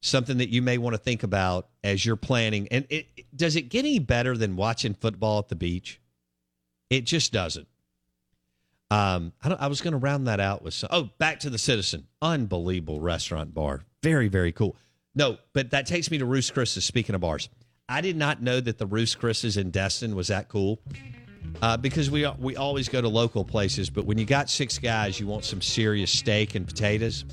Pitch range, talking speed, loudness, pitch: 95-130 Hz, 215 wpm, -26 LUFS, 115 Hz